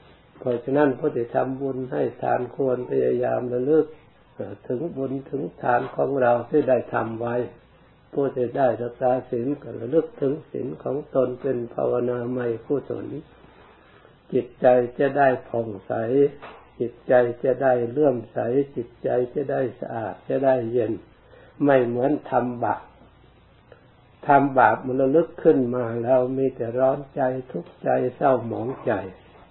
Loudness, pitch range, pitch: -23 LUFS, 120-140 Hz, 125 Hz